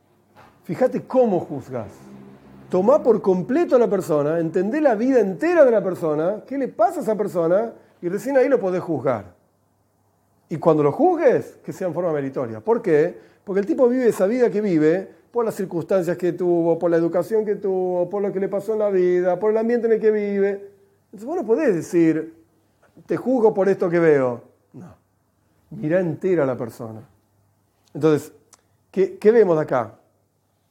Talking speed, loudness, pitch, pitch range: 185 wpm, -20 LUFS, 180 Hz, 140-215 Hz